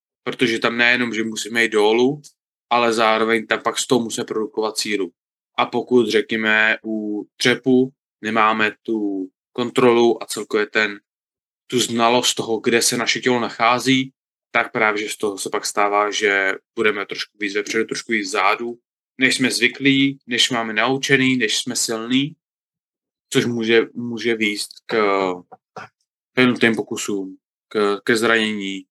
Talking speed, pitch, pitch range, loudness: 145 wpm, 115 Hz, 110-125 Hz, -19 LUFS